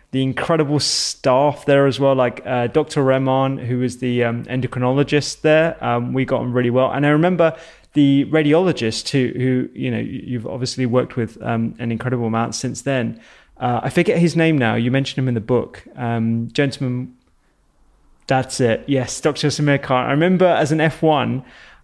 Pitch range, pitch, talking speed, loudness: 120-145 Hz, 130 Hz, 180 wpm, -18 LUFS